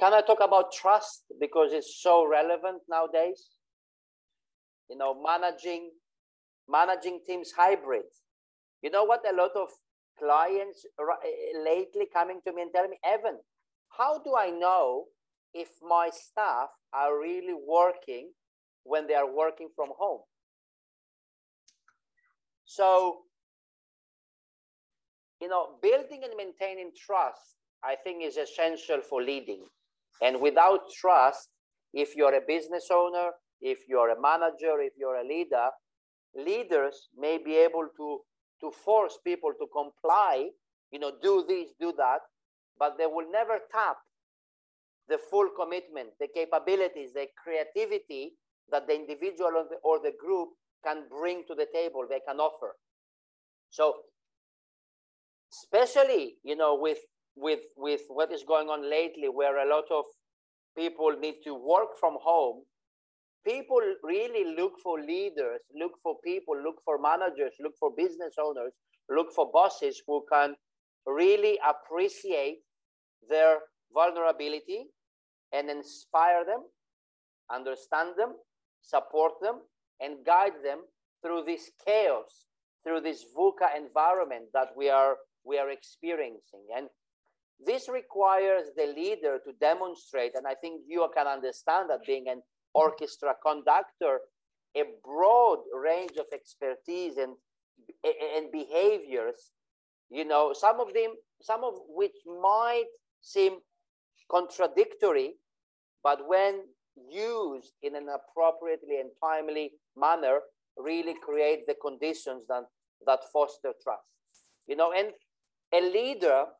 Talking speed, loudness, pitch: 130 wpm, -29 LUFS, 175 Hz